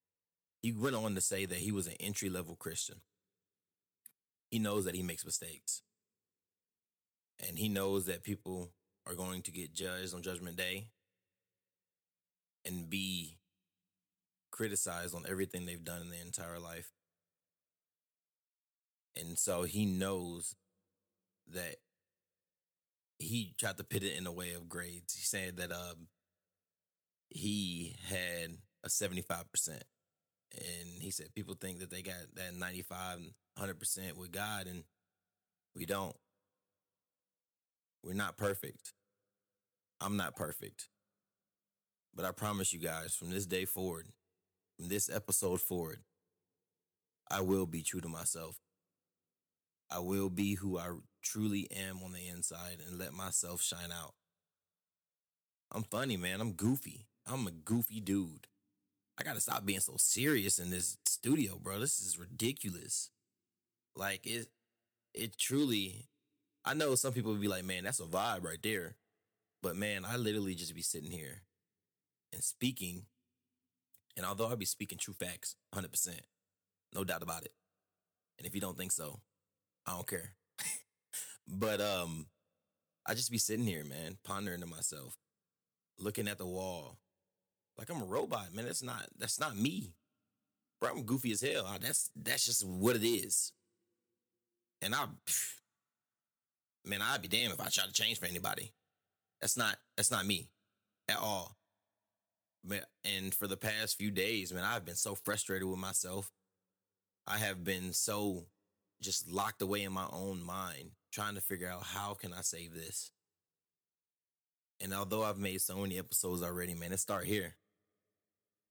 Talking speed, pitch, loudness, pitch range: 150 wpm, 95 Hz, -38 LUFS, 90-100 Hz